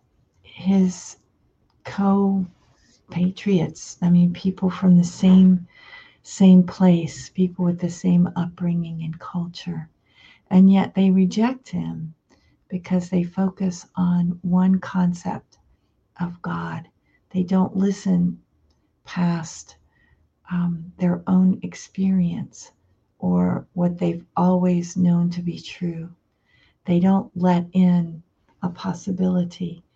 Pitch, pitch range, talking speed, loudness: 180 Hz, 175-185 Hz, 105 wpm, -21 LUFS